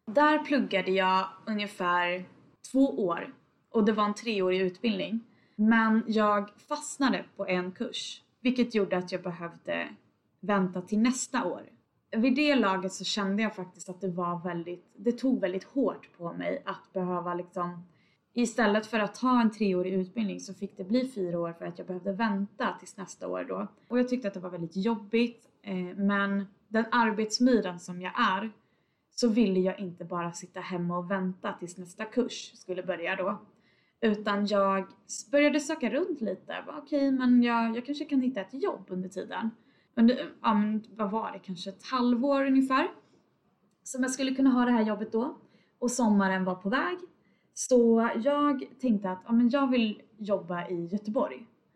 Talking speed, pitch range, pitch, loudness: 175 wpm, 185-240 Hz, 210 Hz, -29 LUFS